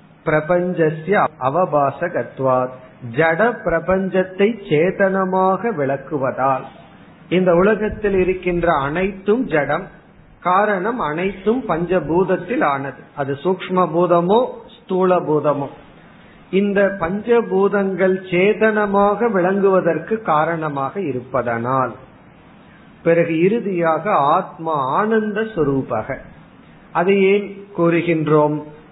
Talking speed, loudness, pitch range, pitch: 70 wpm, -18 LUFS, 155-195 Hz, 180 Hz